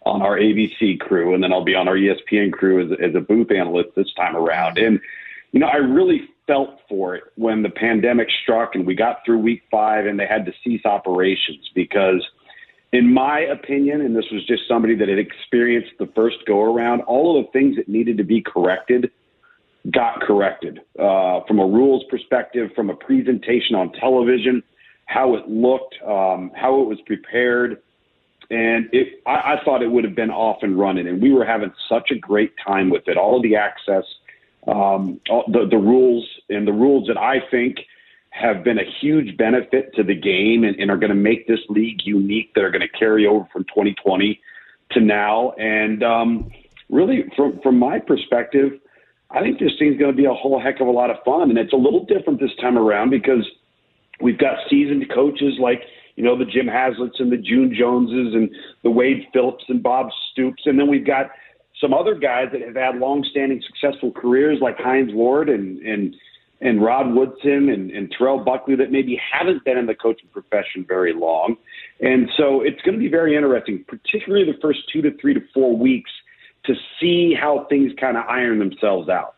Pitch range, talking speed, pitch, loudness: 110-135 Hz, 200 wpm, 120 Hz, -18 LUFS